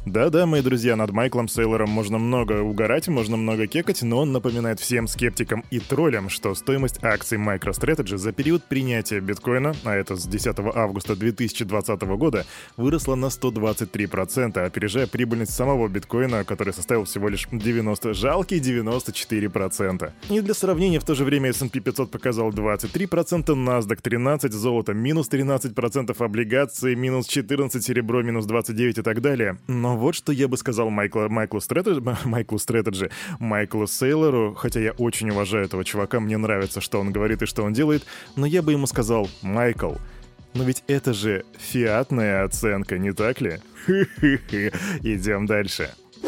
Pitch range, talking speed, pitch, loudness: 105-130 Hz, 155 wpm, 115 Hz, -23 LUFS